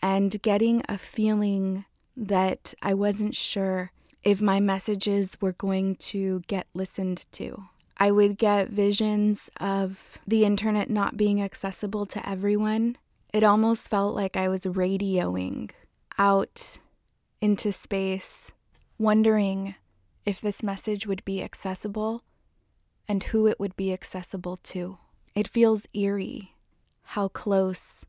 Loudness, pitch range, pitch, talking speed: -26 LUFS, 190-210 Hz, 200 Hz, 125 wpm